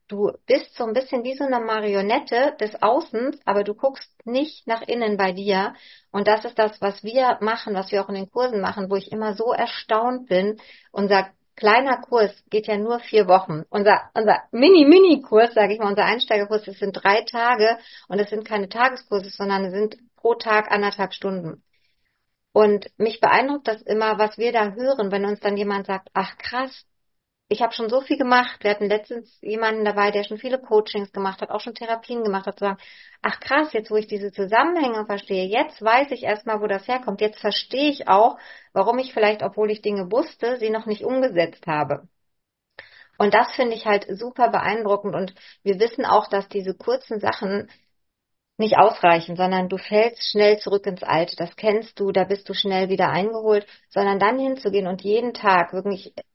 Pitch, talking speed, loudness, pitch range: 215 Hz, 195 wpm, -21 LUFS, 200-235 Hz